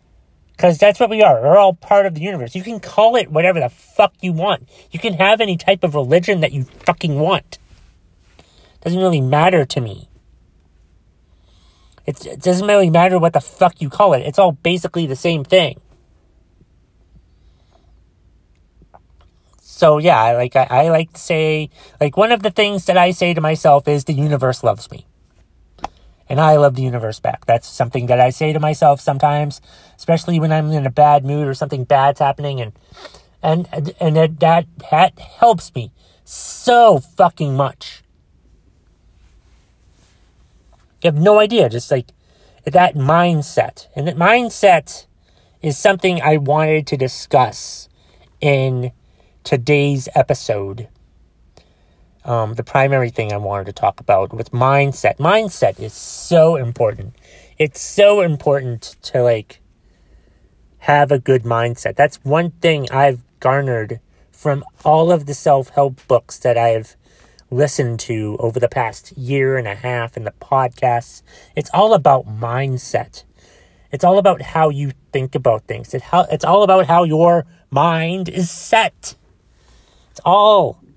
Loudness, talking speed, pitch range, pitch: -15 LUFS, 155 wpm, 105-165 Hz, 140 Hz